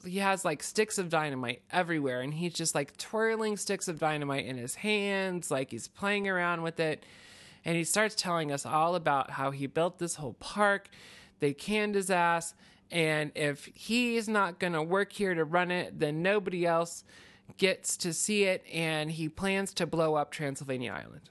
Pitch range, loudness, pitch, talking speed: 150-195 Hz, -31 LUFS, 170 Hz, 185 wpm